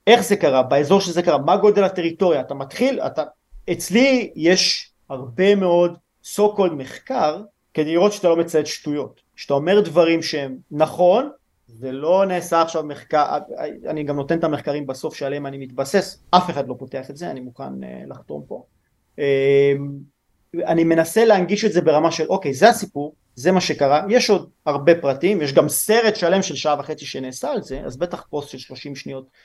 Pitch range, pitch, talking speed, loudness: 140-185 Hz, 160 Hz, 180 wpm, -19 LUFS